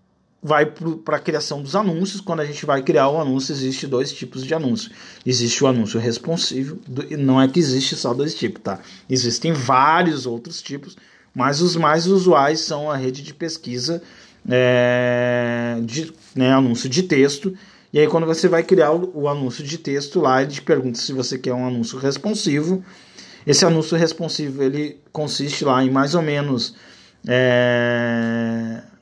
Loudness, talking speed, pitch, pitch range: -19 LUFS, 170 wpm, 140 Hz, 125-160 Hz